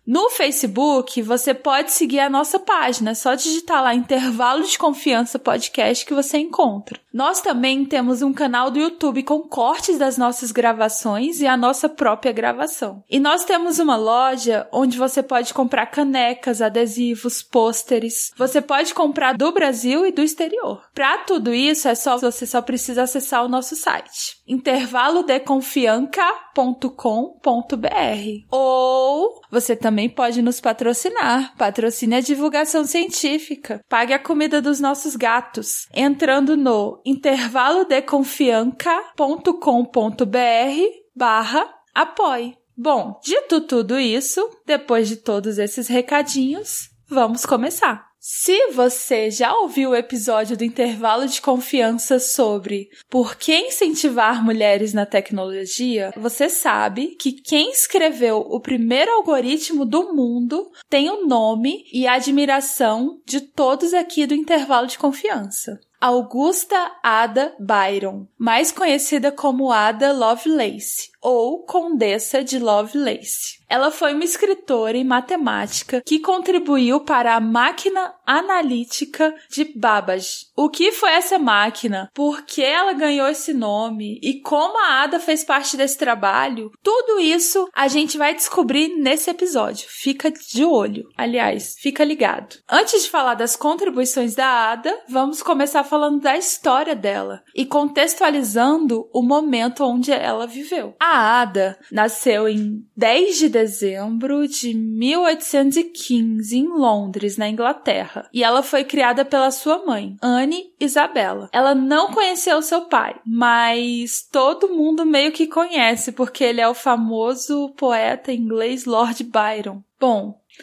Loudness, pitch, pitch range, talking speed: -18 LUFS, 265 Hz, 235-305 Hz, 130 wpm